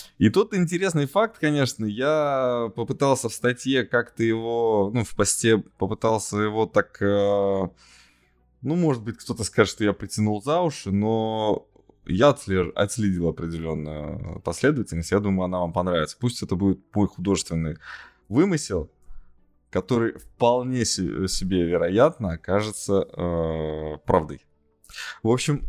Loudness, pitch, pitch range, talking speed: -24 LUFS, 105 Hz, 90-120 Hz, 120 wpm